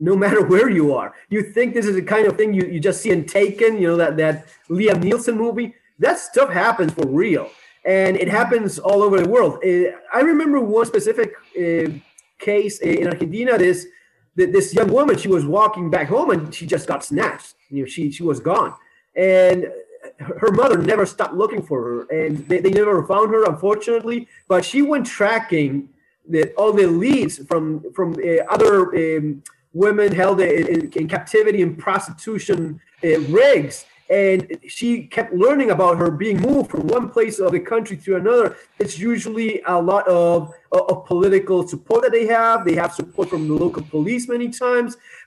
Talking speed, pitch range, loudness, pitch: 185 wpm, 170-235 Hz, -18 LUFS, 195 Hz